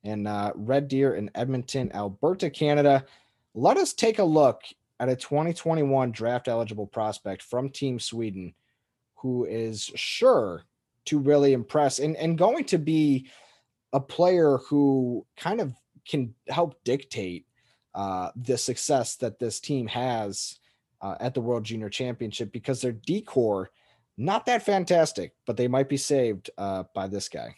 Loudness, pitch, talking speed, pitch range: -26 LUFS, 130 Hz, 150 wpm, 115-145 Hz